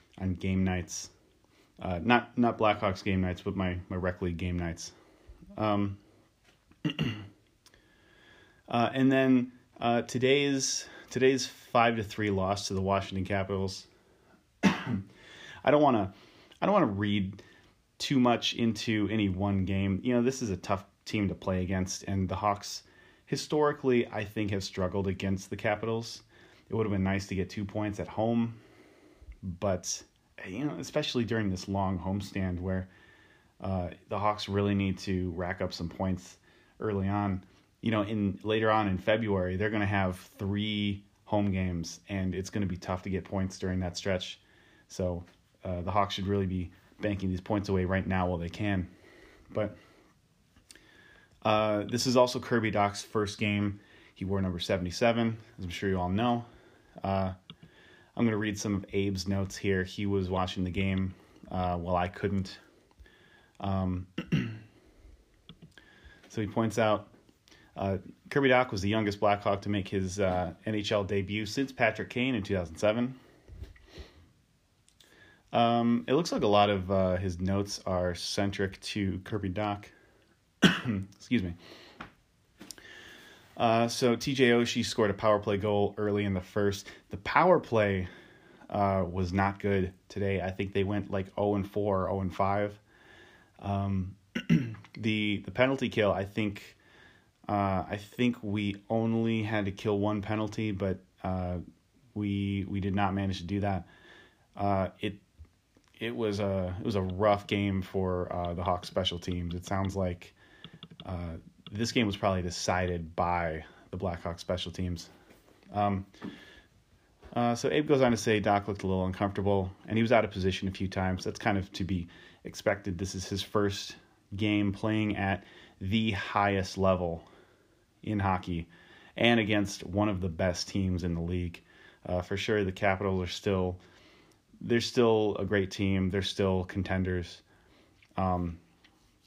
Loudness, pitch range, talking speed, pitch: -31 LUFS, 95-105 Hz, 160 wpm, 100 Hz